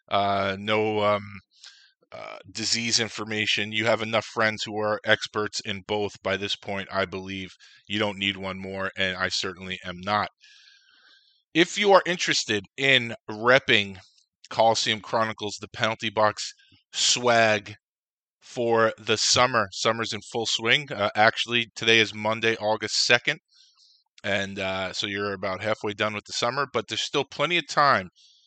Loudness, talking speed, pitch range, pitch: -24 LUFS, 150 wpm, 100-115 Hz, 105 Hz